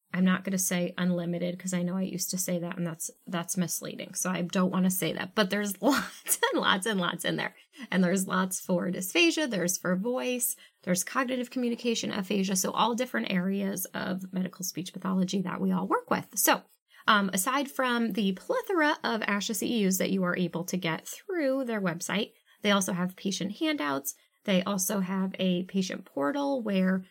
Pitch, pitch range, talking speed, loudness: 190 Hz, 180-230 Hz, 195 wpm, -29 LUFS